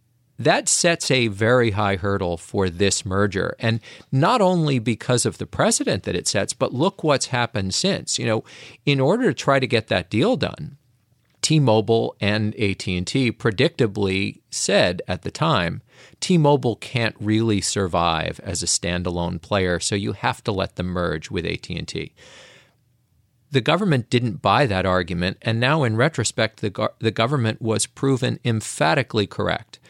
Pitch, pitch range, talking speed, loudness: 115 Hz, 100-130 Hz, 155 wpm, -21 LUFS